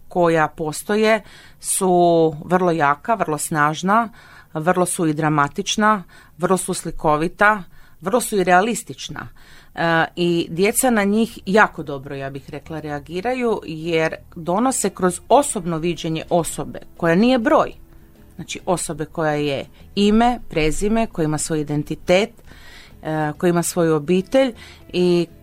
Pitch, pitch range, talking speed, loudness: 175 Hz, 155-205 Hz, 125 wpm, -19 LUFS